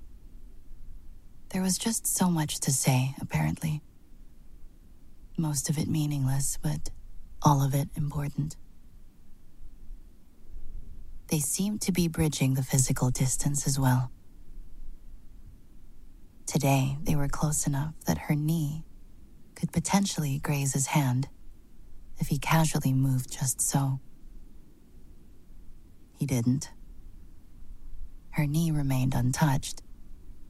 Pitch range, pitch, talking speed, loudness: 95-150 Hz, 135 Hz, 100 wpm, -28 LUFS